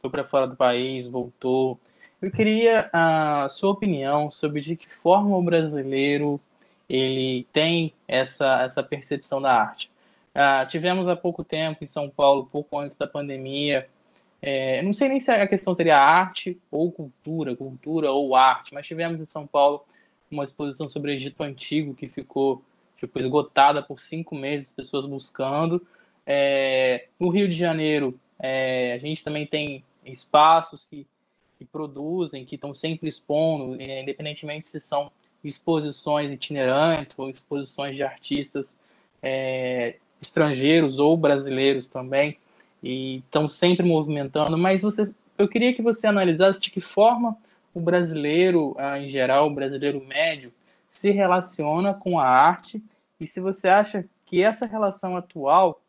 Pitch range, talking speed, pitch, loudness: 135-170 Hz, 150 wpm, 150 Hz, -23 LUFS